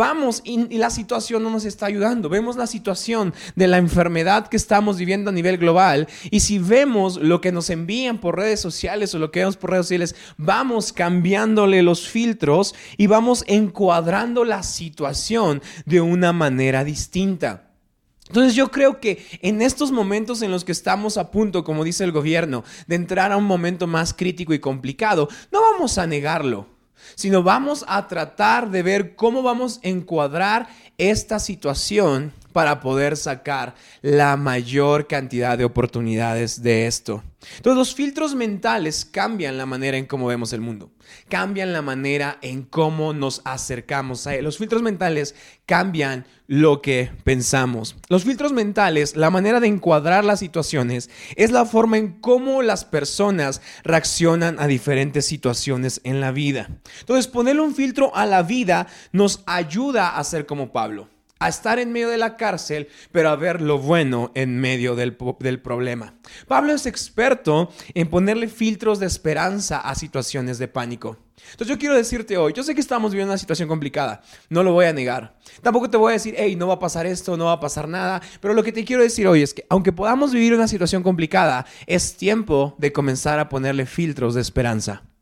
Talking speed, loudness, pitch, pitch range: 180 wpm, -20 LUFS, 175 Hz, 140-215 Hz